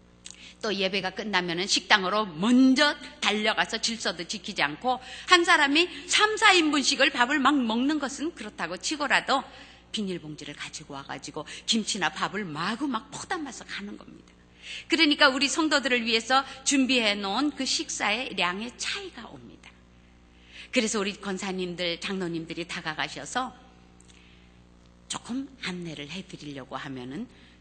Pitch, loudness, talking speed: 200 Hz, -25 LUFS, 305 characters per minute